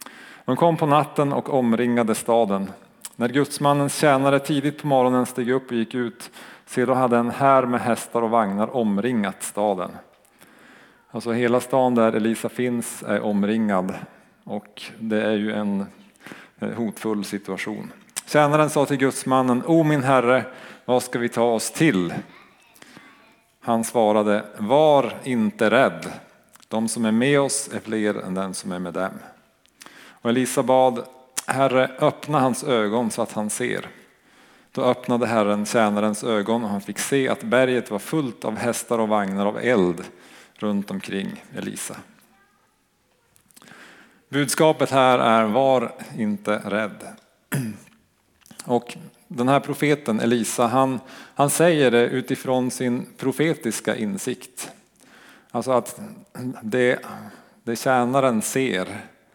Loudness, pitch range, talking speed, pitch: -22 LUFS, 110-135 Hz, 135 wpm, 125 Hz